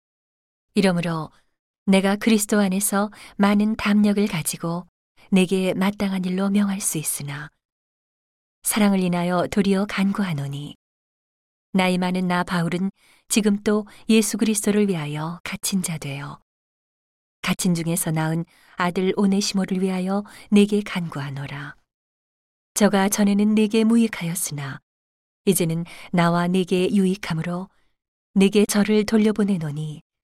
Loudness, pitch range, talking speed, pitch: -22 LUFS, 170-205 Hz, 265 characters per minute, 190 Hz